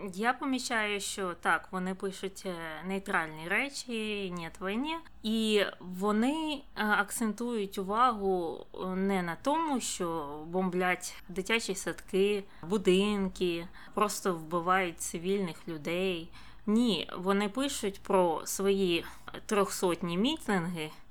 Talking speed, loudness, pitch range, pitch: 90 wpm, -32 LUFS, 180-215 Hz, 195 Hz